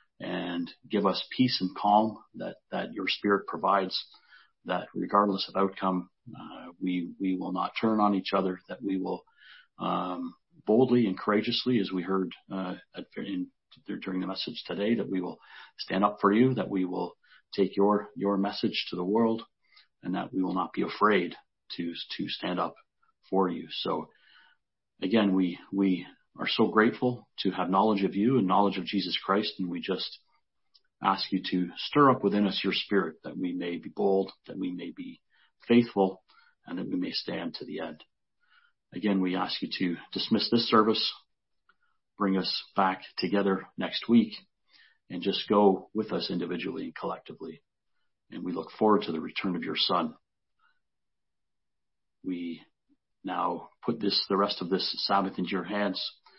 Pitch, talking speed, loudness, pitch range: 100 Hz, 170 wpm, -29 LUFS, 90-110 Hz